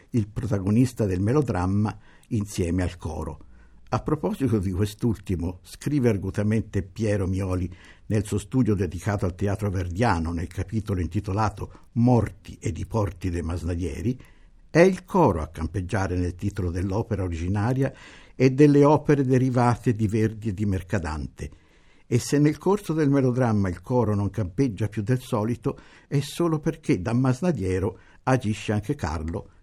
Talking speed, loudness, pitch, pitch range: 140 wpm, -25 LUFS, 105 Hz, 90-125 Hz